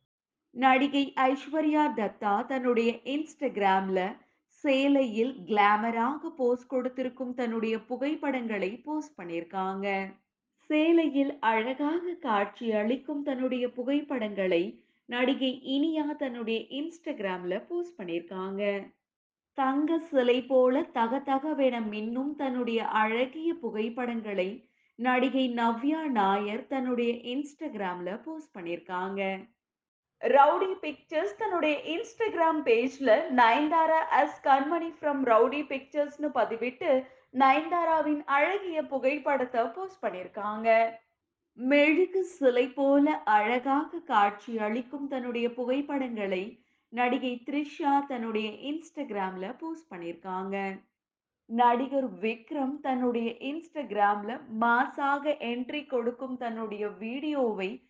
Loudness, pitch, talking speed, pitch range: -29 LUFS, 255 Hz, 85 wpm, 225-290 Hz